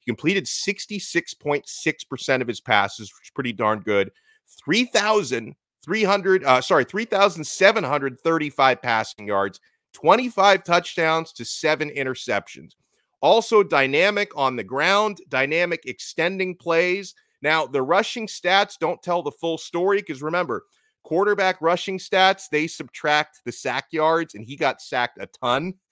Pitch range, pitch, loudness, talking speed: 135-195 Hz, 165 Hz, -22 LUFS, 125 wpm